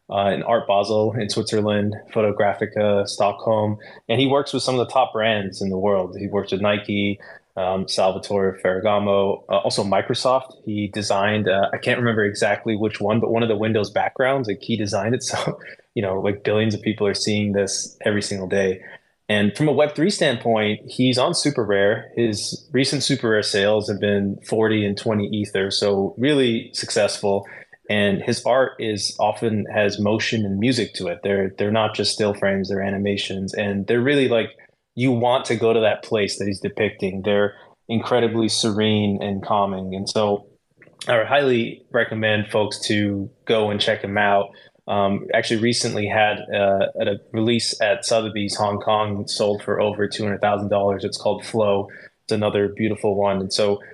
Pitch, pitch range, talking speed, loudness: 105 Hz, 100-115 Hz, 180 wpm, -21 LUFS